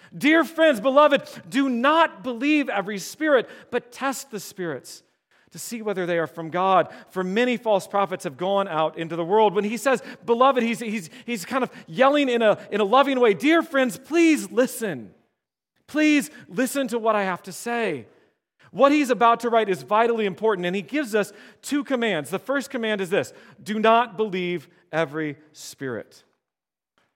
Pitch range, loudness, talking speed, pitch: 190-265 Hz, -22 LUFS, 180 wpm, 225 Hz